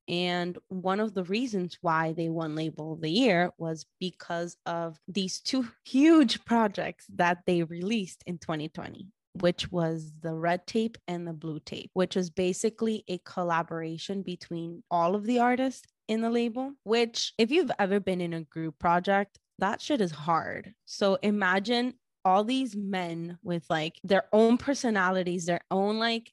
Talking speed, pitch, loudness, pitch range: 165 wpm, 185 Hz, -29 LUFS, 170-220 Hz